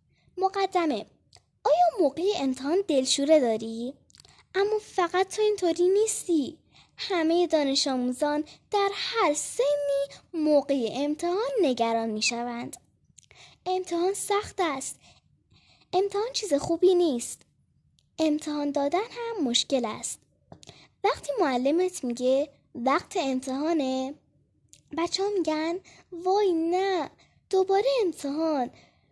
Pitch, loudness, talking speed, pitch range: 330 Hz, -27 LUFS, 95 wpm, 280-375 Hz